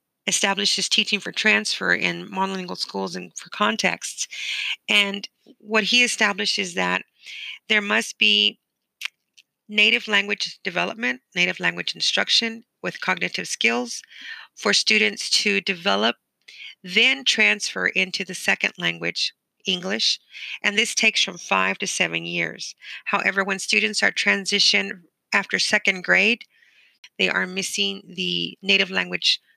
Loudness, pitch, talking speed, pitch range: -20 LUFS, 200 Hz, 125 wpm, 185-220 Hz